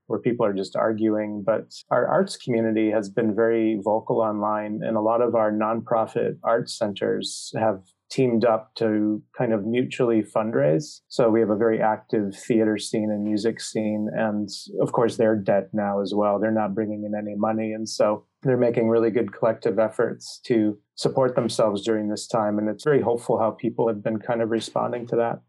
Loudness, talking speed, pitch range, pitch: -24 LUFS, 195 wpm, 105-115 Hz, 110 Hz